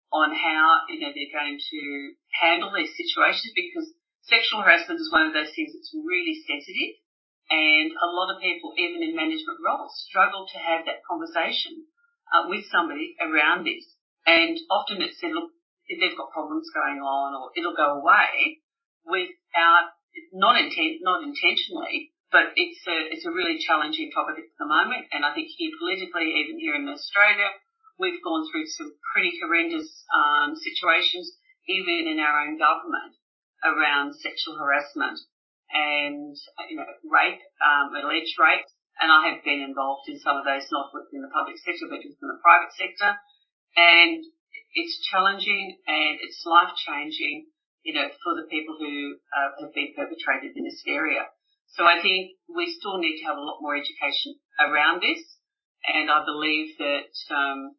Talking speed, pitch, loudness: 165 wpm, 300 Hz, -23 LUFS